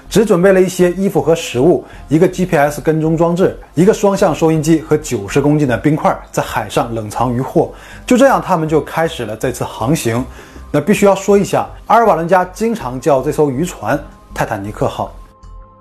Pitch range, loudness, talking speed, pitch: 130-185 Hz, -14 LUFS, 300 characters per minute, 160 Hz